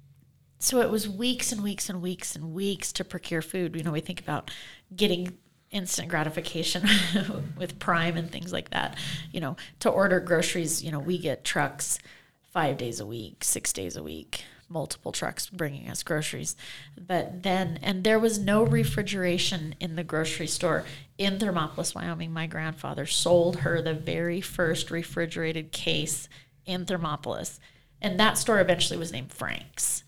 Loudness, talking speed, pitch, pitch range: -28 LUFS, 165 wpm, 170 Hz, 155-185 Hz